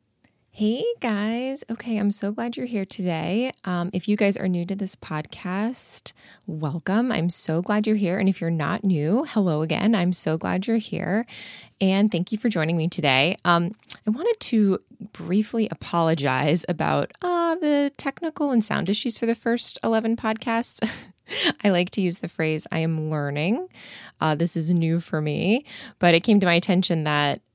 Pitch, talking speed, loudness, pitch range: 195 Hz, 180 wpm, -23 LUFS, 170-225 Hz